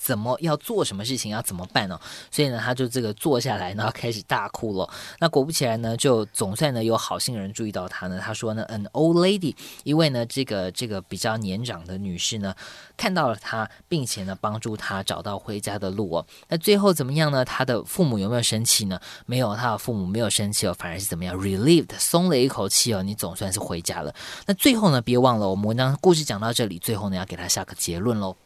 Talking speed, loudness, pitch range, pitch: 370 characters per minute, -24 LUFS, 95-130 Hz, 110 Hz